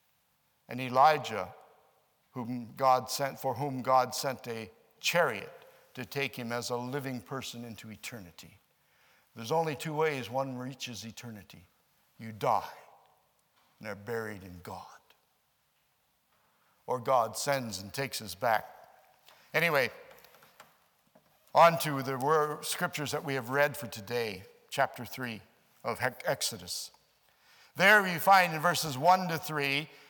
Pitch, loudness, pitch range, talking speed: 130 Hz, -30 LUFS, 115-145 Hz, 130 wpm